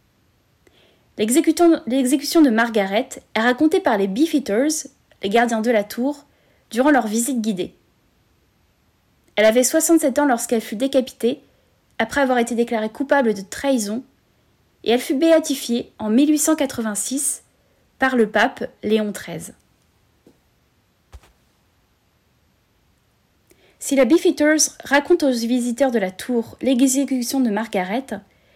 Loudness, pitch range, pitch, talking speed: -19 LUFS, 220-285 Hz, 250 Hz, 115 wpm